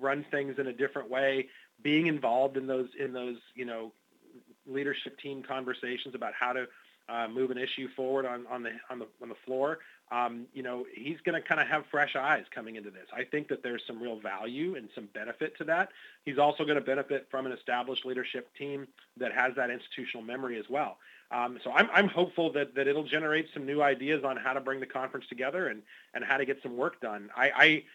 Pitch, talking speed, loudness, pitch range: 135 Hz, 225 wpm, -32 LUFS, 125-145 Hz